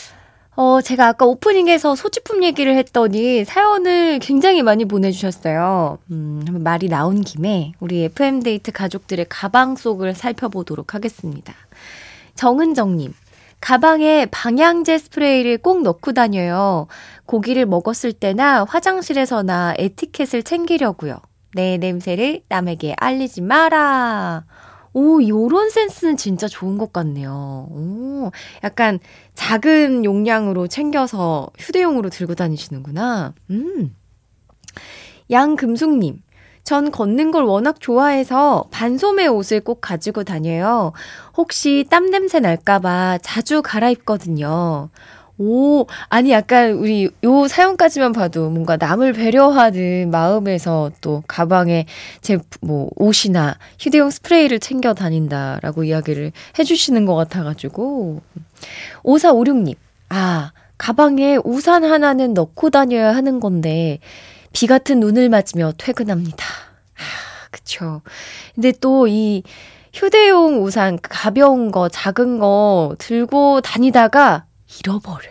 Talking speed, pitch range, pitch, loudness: 260 characters per minute, 175-275 Hz, 220 Hz, -16 LUFS